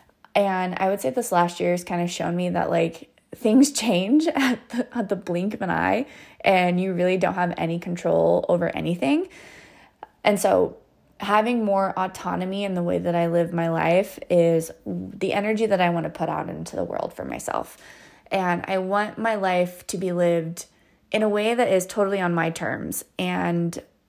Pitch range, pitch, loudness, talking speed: 175-210 Hz, 185 Hz, -23 LUFS, 195 wpm